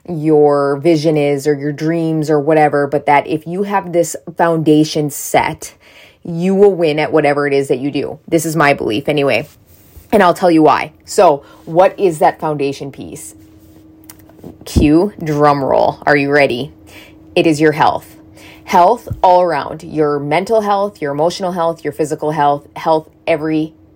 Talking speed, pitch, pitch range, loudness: 165 wpm, 155 Hz, 145-165 Hz, -14 LUFS